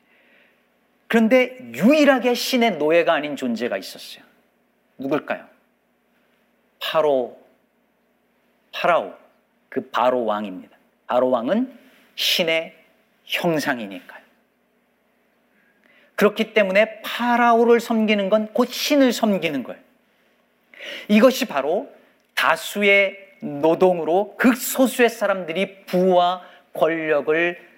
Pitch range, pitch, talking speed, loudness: 175-245 Hz, 215 Hz, 210 characters per minute, -20 LUFS